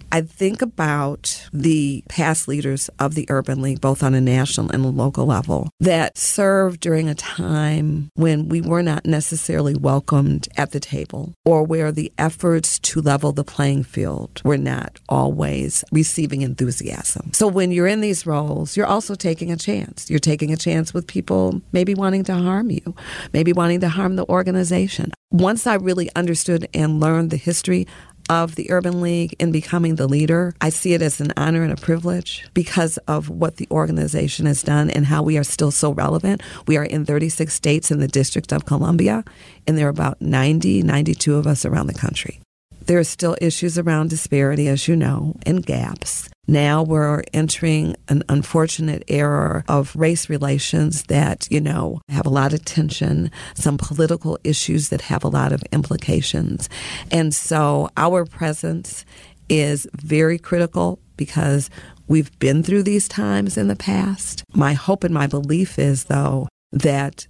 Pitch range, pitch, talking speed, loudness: 145-170 Hz, 155 Hz, 175 wpm, -19 LUFS